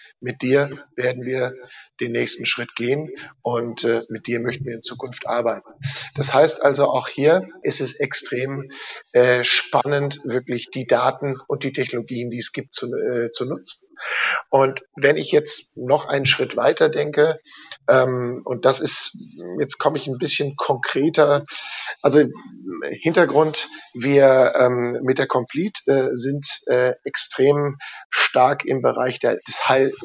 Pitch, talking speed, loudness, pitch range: 135 Hz, 150 wpm, -19 LUFS, 125-145 Hz